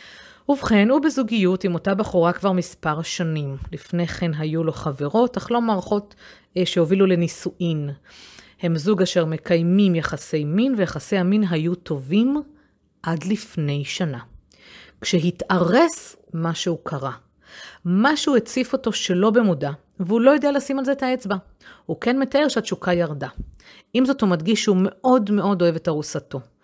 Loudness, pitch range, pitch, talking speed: -21 LUFS, 165-220 Hz, 185 Hz, 140 wpm